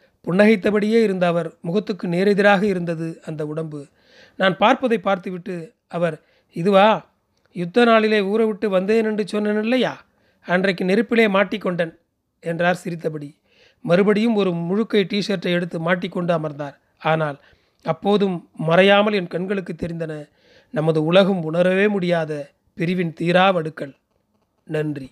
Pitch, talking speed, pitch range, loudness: 185 Hz, 110 wpm, 165-205 Hz, -20 LUFS